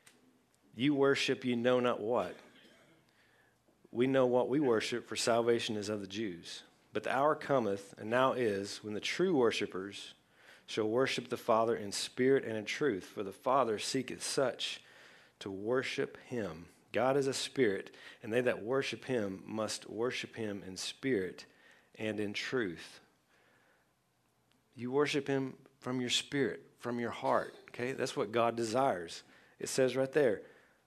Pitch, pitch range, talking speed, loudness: 120 Hz, 105-135 Hz, 155 wpm, -34 LUFS